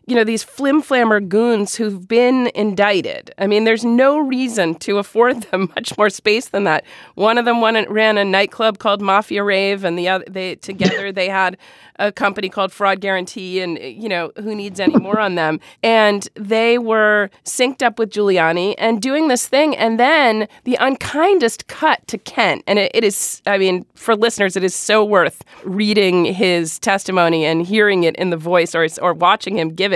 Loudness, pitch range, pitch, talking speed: -16 LUFS, 190-230 Hz, 205 Hz, 195 wpm